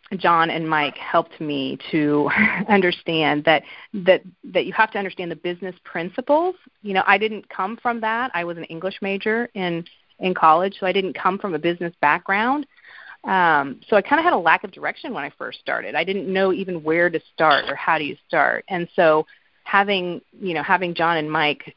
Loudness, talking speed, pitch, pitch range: -21 LUFS, 205 wpm, 185 Hz, 165-200 Hz